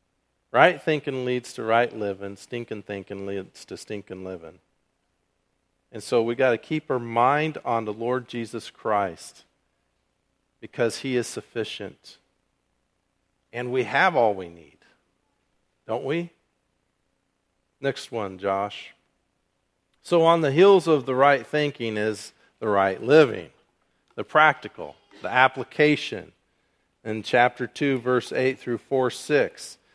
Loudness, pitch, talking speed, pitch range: -23 LUFS, 115 Hz, 130 wpm, 100-130 Hz